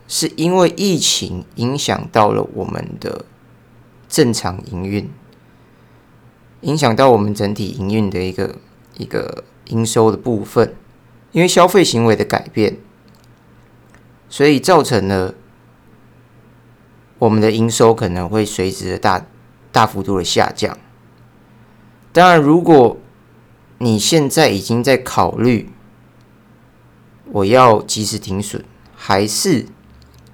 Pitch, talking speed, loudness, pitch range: 110 Hz, 170 characters per minute, -15 LUFS, 100-125 Hz